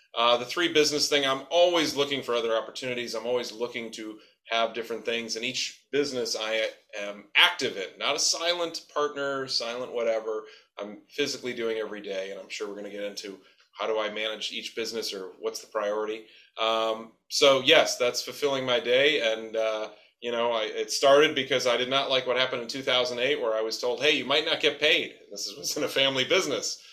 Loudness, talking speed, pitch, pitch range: -26 LUFS, 210 wpm, 120 Hz, 110-140 Hz